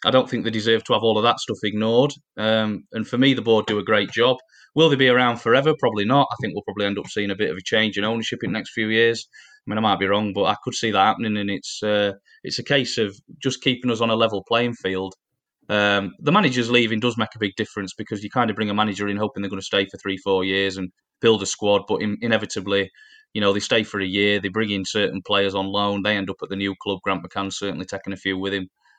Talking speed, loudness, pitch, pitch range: 285 wpm, -21 LUFS, 105 Hz, 100-115 Hz